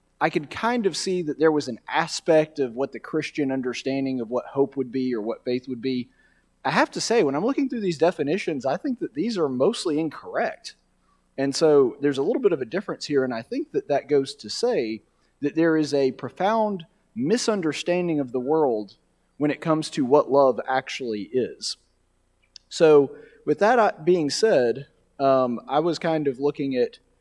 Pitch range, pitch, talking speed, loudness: 130-175 Hz, 150 Hz, 195 wpm, -24 LUFS